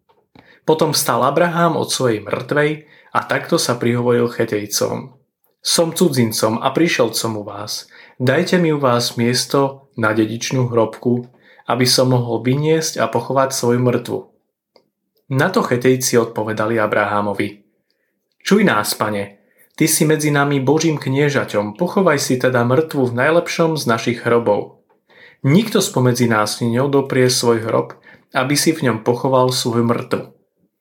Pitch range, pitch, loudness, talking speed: 115-150 Hz, 125 Hz, -17 LUFS, 135 wpm